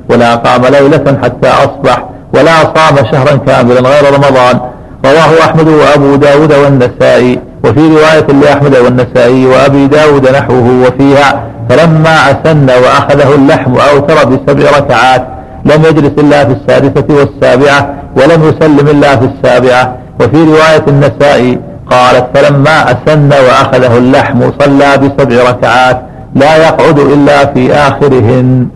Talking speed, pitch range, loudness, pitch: 120 wpm, 125-150 Hz, -5 LUFS, 140 Hz